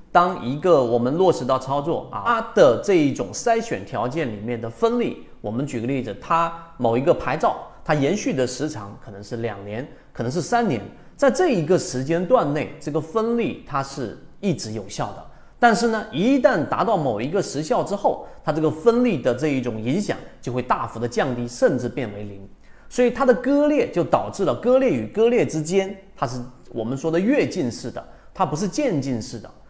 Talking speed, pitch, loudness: 290 characters per minute, 150 Hz, -22 LUFS